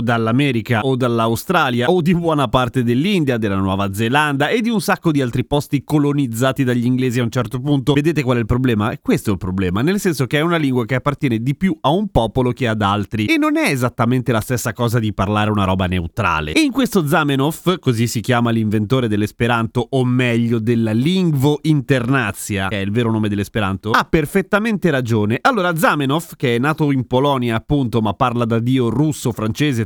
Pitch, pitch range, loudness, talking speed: 125 Hz, 115-150 Hz, -17 LUFS, 200 wpm